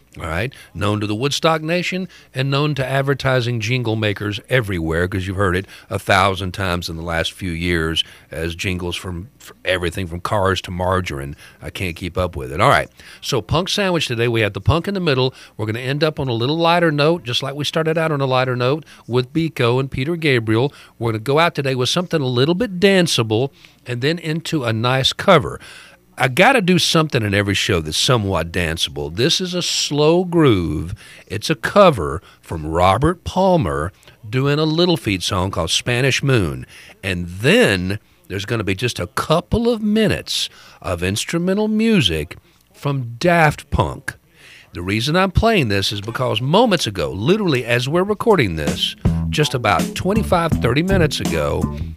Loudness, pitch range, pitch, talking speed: -18 LUFS, 95-160 Hz, 125 Hz, 185 wpm